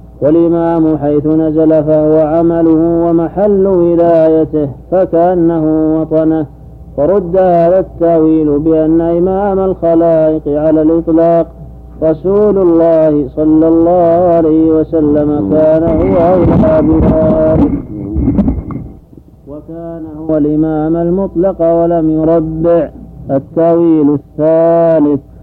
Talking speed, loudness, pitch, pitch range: 80 wpm, -10 LUFS, 160 Hz, 155-170 Hz